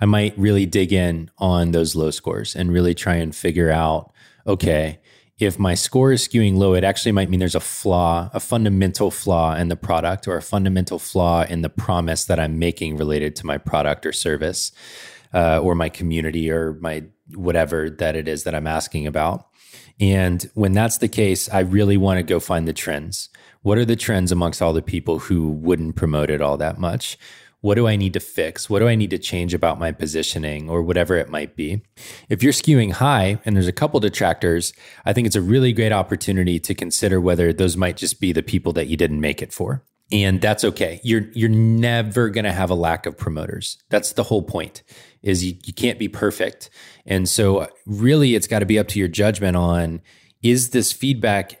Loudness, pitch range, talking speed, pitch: -20 LUFS, 85-105 Hz, 210 wpm, 95 Hz